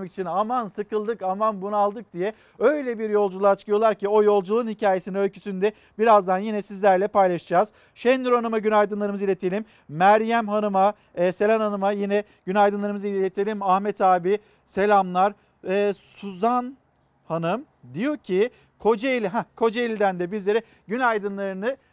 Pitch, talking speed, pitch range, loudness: 205 Hz, 125 wpm, 195-220 Hz, -23 LUFS